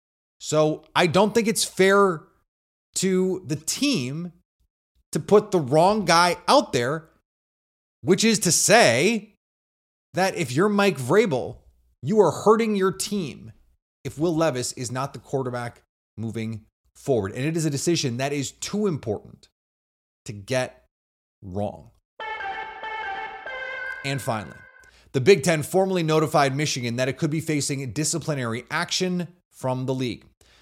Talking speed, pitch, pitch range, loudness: 135 wpm, 155 Hz, 125-190 Hz, -23 LUFS